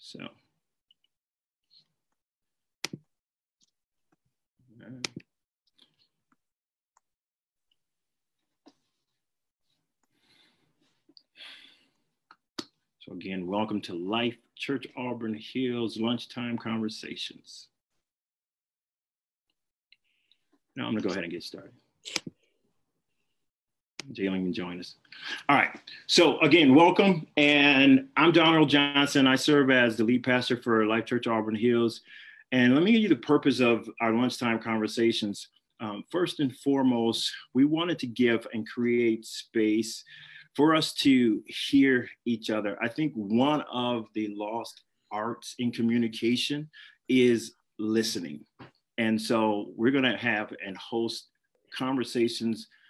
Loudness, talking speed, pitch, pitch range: -26 LUFS, 105 wpm, 120 Hz, 110-130 Hz